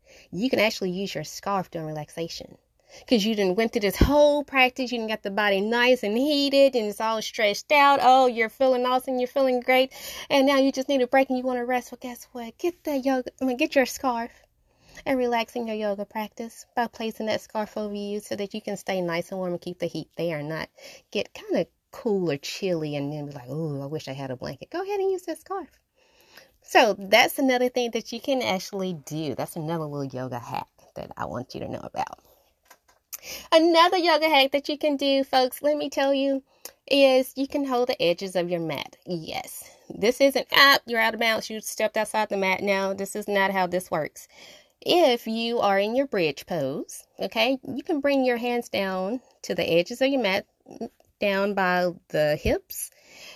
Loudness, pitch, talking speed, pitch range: -24 LUFS, 230 Hz, 220 wpm, 195-270 Hz